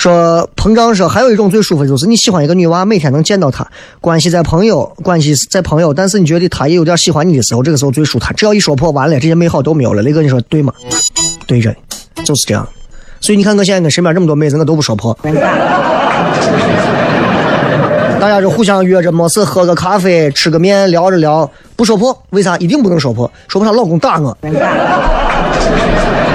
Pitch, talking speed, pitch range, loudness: 170 Hz, 330 characters per minute, 150-190 Hz, -10 LUFS